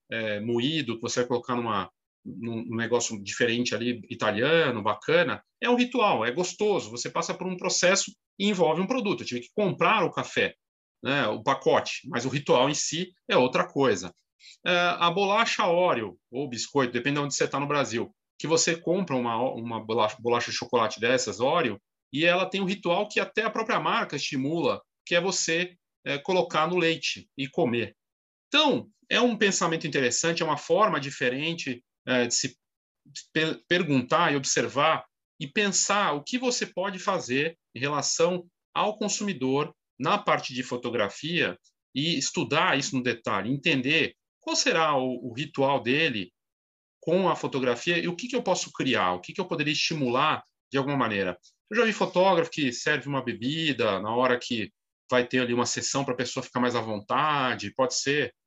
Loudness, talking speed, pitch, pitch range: -26 LUFS, 180 wpm, 150 Hz, 125-180 Hz